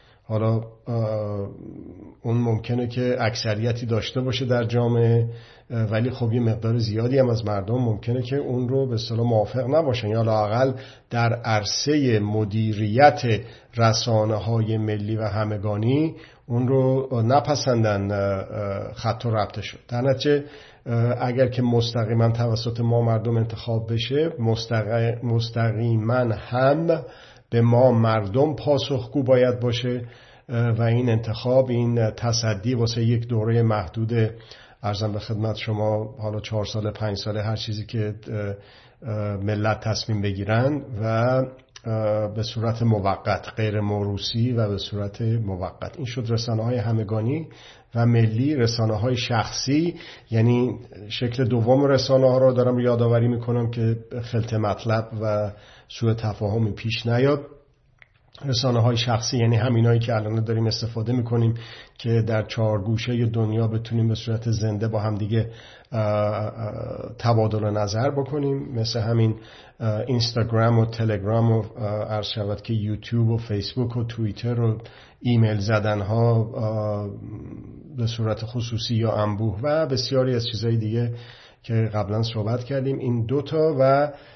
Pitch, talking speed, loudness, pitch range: 115 Hz, 130 wpm, -23 LUFS, 110-125 Hz